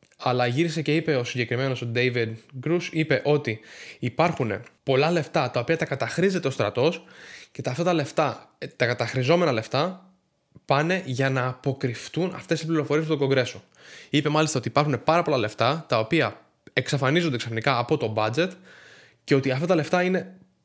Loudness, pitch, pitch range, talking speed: -24 LUFS, 145 Hz, 125-165 Hz, 165 wpm